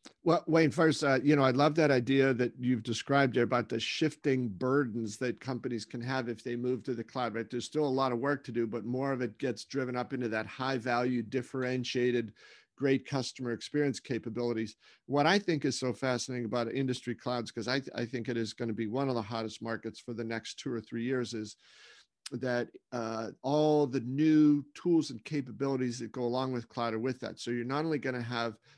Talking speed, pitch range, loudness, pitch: 225 wpm, 120-135 Hz, -32 LUFS, 125 Hz